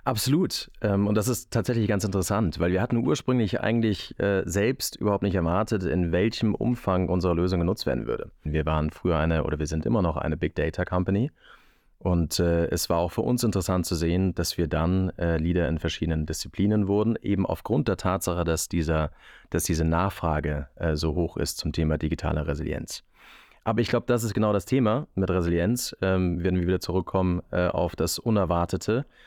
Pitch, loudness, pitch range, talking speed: 90 Hz, -26 LUFS, 85-105 Hz, 180 wpm